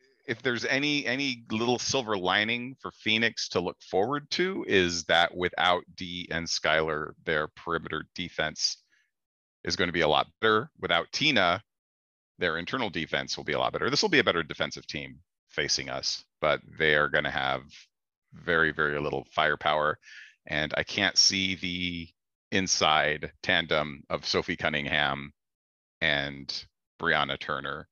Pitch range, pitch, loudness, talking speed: 75-115 Hz, 90 Hz, -27 LUFS, 155 wpm